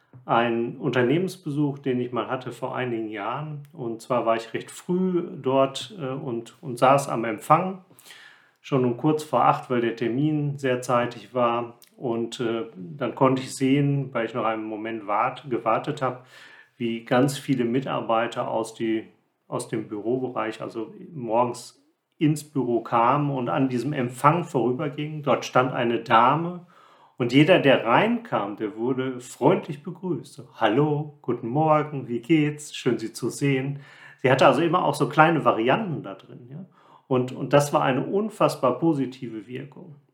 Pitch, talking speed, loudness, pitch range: 130 Hz, 160 wpm, -24 LUFS, 120-150 Hz